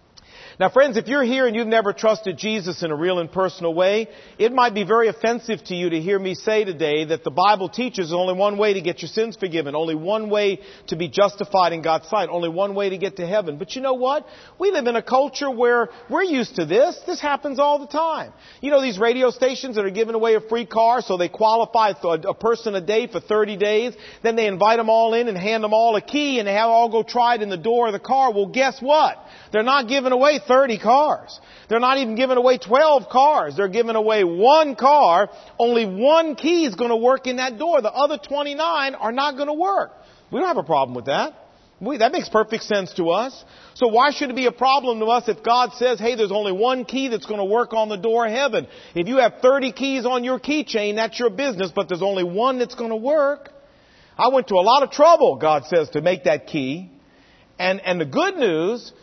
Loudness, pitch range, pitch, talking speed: -20 LUFS, 200-260 Hz, 230 Hz, 240 wpm